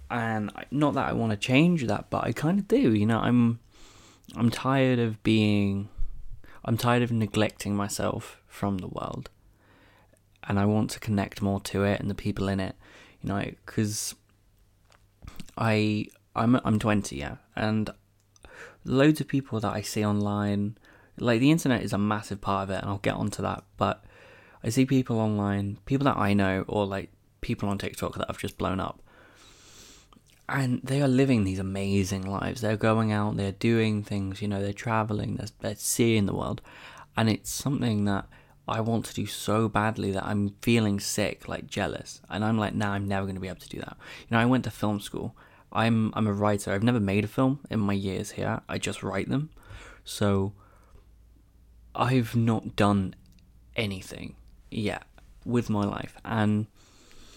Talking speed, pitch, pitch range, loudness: 185 wpm, 105 Hz, 100-115 Hz, -27 LUFS